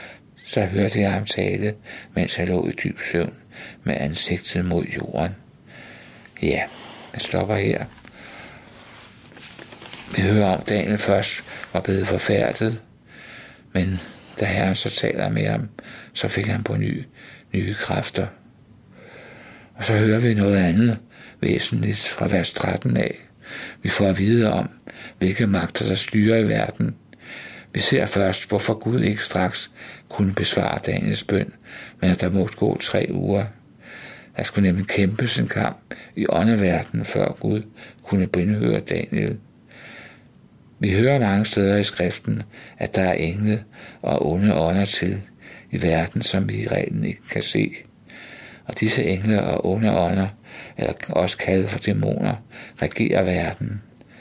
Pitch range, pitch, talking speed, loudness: 95-105 Hz, 100 Hz, 145 wpm, -22 LUFS